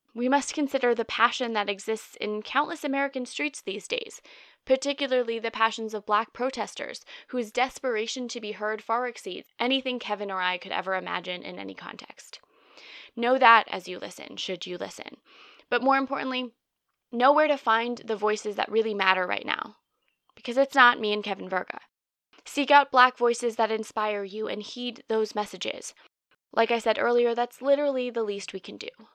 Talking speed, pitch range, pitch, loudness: 180 wpm, 215-265 Hz, 240 Hz, -26 LUFS